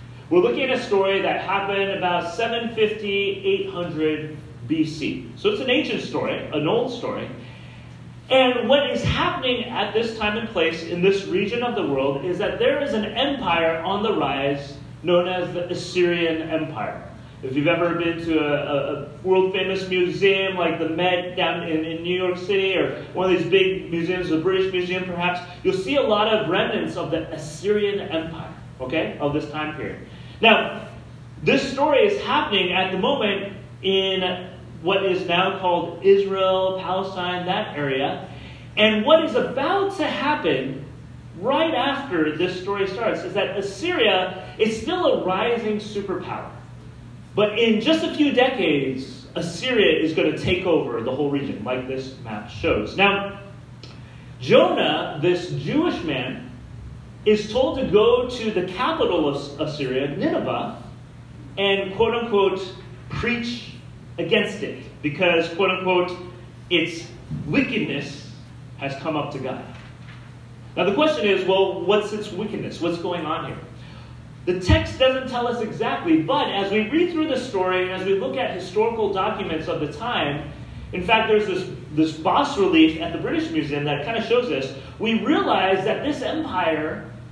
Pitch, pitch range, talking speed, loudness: 180 Hz, 155-215 Hz, 160 wpm, -22 LUFS